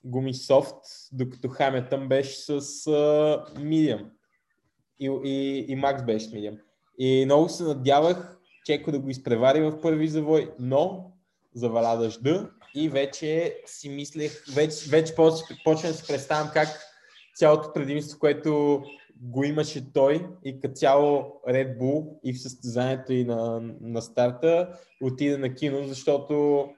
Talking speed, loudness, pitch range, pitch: 140 wpm, -25 LUFS, 130-155 Hz, 145 Hz